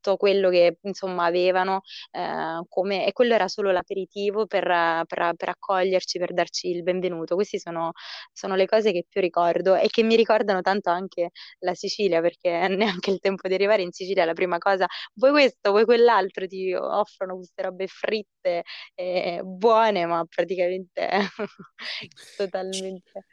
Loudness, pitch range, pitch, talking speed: -24 LUFS, 180-200 Hz, 190 Hz, 155 wpm